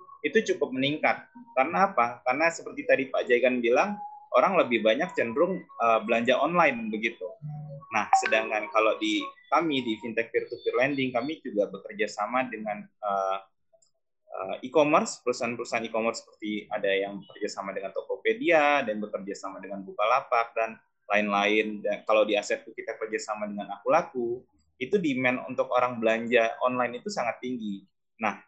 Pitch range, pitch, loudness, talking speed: 105-150 Hz, 120 Hz, -27 LUFS, 155 wpm